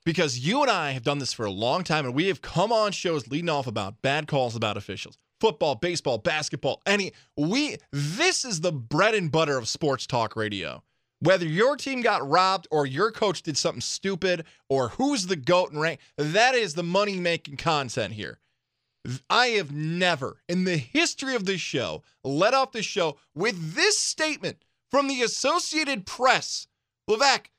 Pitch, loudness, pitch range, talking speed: 170 Hz, -25 LUFS, 140-215 Hz, 185 wpm